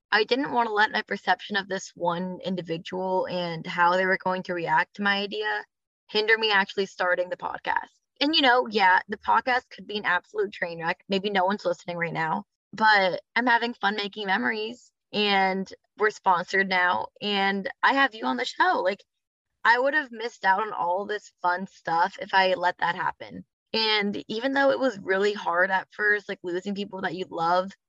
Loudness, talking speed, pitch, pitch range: -25 LUFS, 200 wpm, 195 Hz, 185-215 Hz